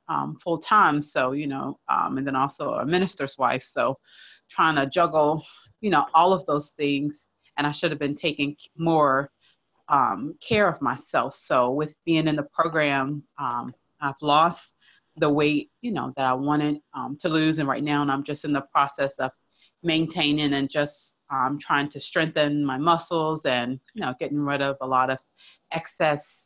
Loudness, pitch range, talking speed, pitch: -24 LUFS, 140-160 Hz, 185 wpm, 145 Hz